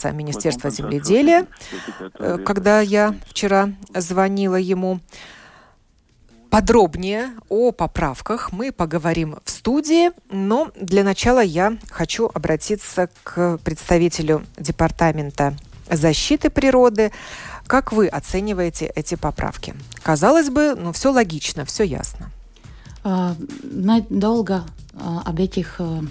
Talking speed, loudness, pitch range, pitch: 90 wpm, -19 LUFS, 165-220 Hz, 190 Hz